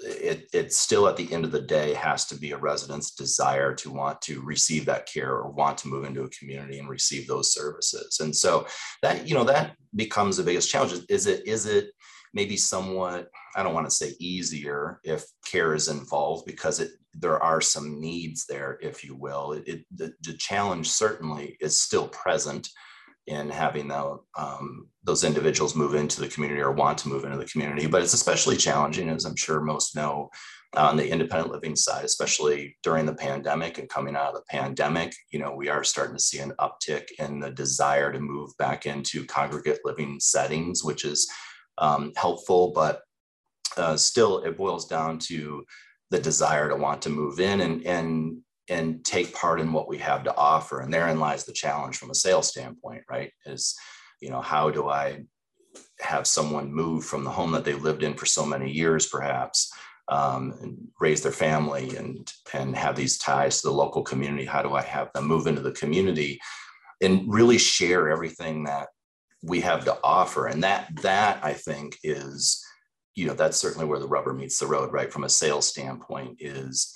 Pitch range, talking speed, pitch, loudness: 70-85 Hz, 195 wpm, 75 Hz, -25 LUFS